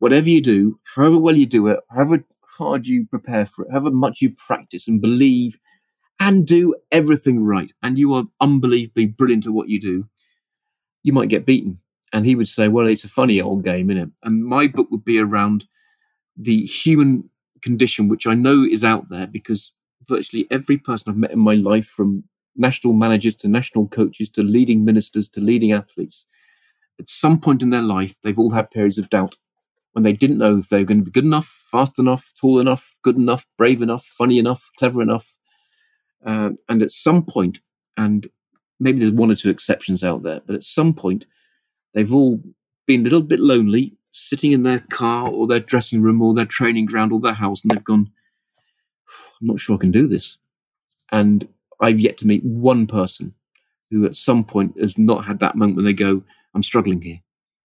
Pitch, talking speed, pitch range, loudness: 115 Hz, 200 wpm, 105-135 Hz, -17 LUFS